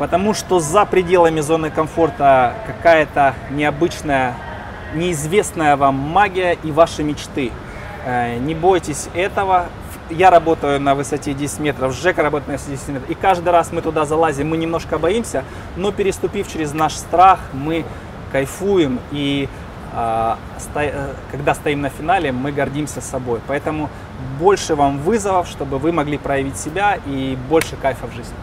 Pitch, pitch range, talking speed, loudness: 150 Hz, 135-170 Hz, 140 wpm, -18 LUFS